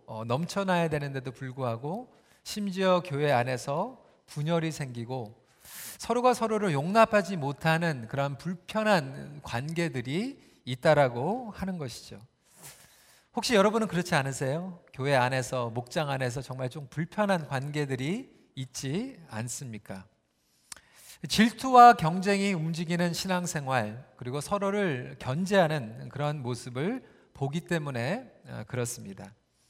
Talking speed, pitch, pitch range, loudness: 275 characters per minute, 150 Hz, 130-190 Hz, -28 LUFS